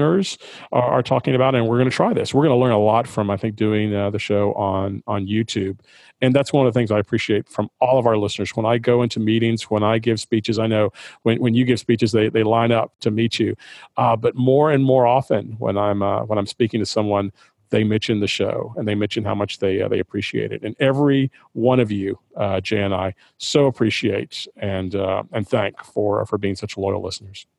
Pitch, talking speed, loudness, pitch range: 110 Hz, 240 wpm, -20 LUFS, 100-120 Hz